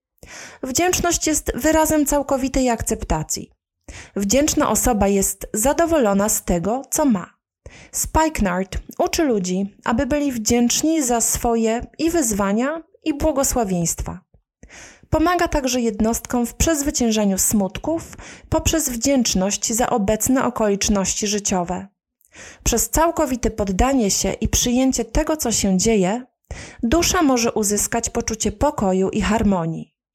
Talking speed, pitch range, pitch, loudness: 105 wpm, 205-290 Hz, 235 Hz, -19 LUFS